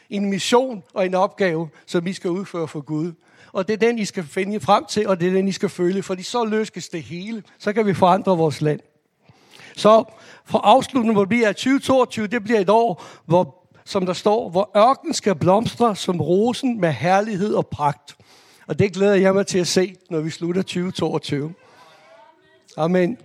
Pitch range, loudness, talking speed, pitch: 175-215 Hz, -20 LUFS, 195 wpm, 190 Hz